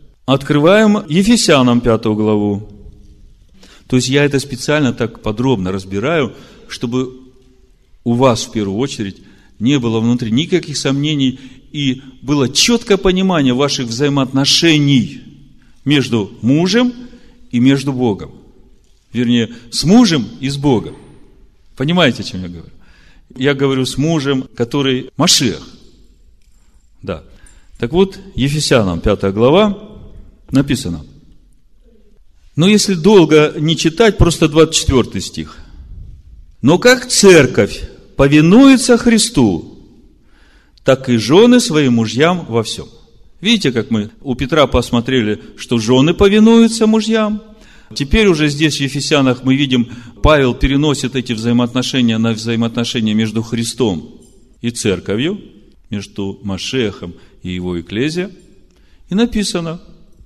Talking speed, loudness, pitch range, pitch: 110 wpm, -13 LUFS, 110-160 Hz, 130 Hz